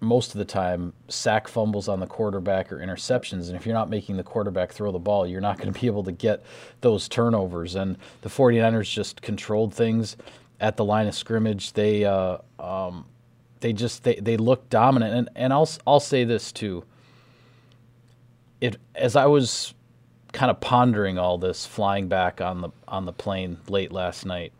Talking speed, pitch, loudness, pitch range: 190 wpm, 110 Hz, -24 LUFS, 95-120 Hz